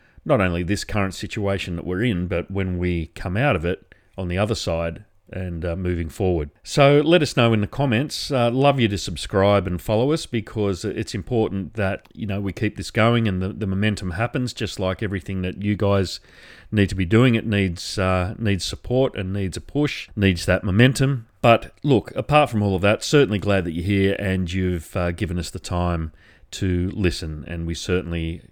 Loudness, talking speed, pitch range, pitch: -22 LUFS, 210 wpm, 90-110 Hz, 100 Hz